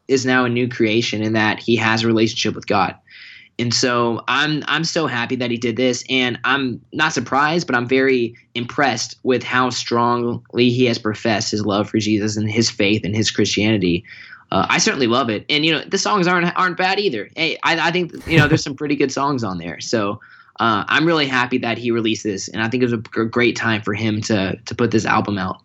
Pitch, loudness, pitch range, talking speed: 120 Hz, -18 LUFS, 110-135 Hz, 230 wpm